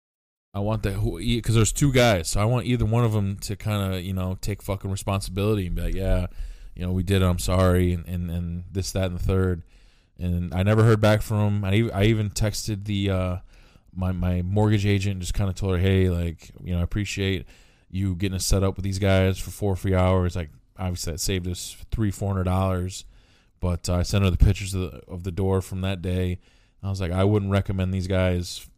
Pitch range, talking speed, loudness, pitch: 90-100 Hz, 240 wpm, -25 LUFS, 95 Hz